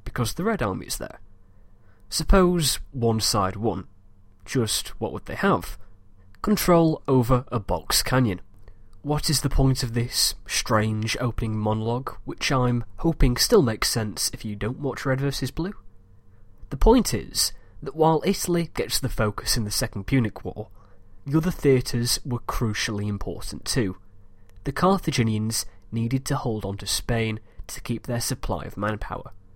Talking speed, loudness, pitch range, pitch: 155 wpm, -24 LUFS, 100-135 Hz, 115 Hz